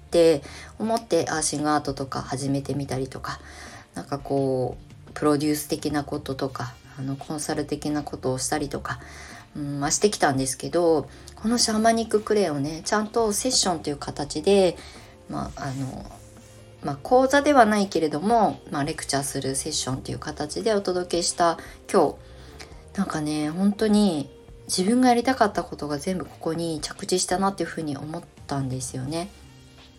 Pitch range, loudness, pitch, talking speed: 135-185 Hz, -24 LUFS, 150 Hz, 360 characters per minute